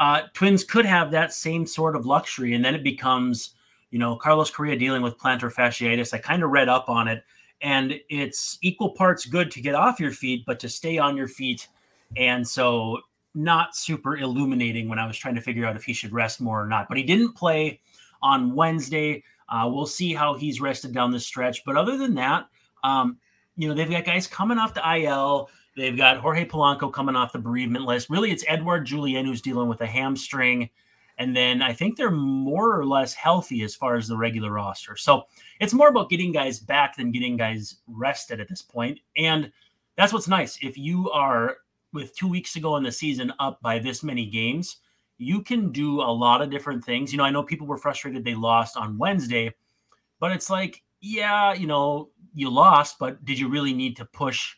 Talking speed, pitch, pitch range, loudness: 210 wpm, 140 Hz, 120-160 Hz, -23 LUFS